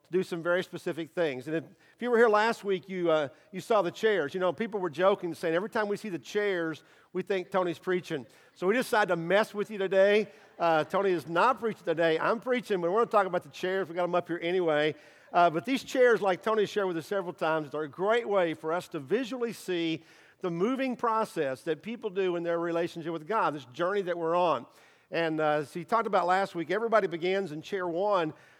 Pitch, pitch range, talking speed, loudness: 180 Hz, 165-205 Hz, 240 wpm, -29 LUFS